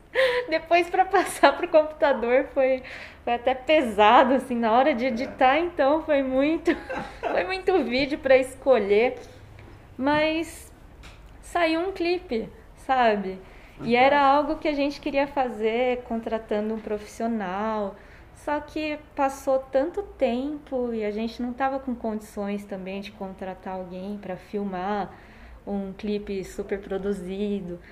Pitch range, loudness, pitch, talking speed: 210-295 Hz, -24 LUFS, 255 Hz, 130 wpm